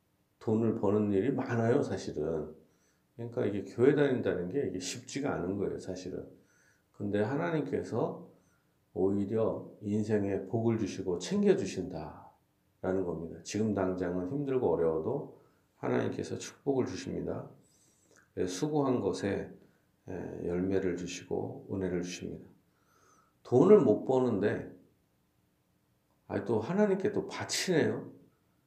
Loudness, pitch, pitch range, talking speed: -32 LUFS, 100 Hz, 95-120 Hz, 265 characters per minute